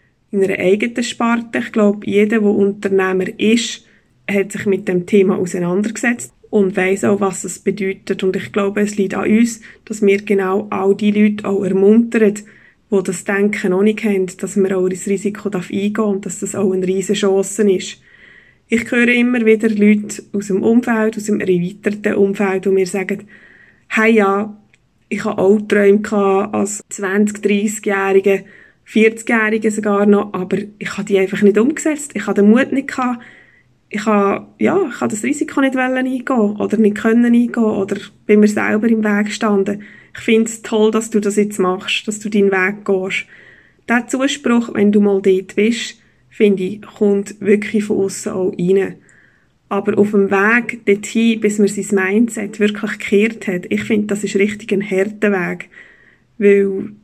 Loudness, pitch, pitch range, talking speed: -16 LUFS, 205 Hz, 195-220 Hz, 180 wpm